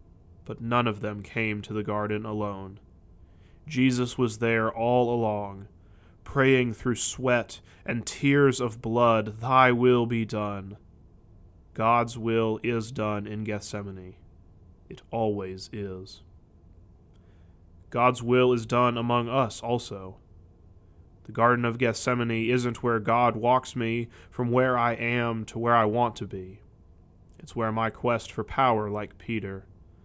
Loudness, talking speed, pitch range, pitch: -26 LUFS, 135 wpm, 95-120 Hz, 110 Hz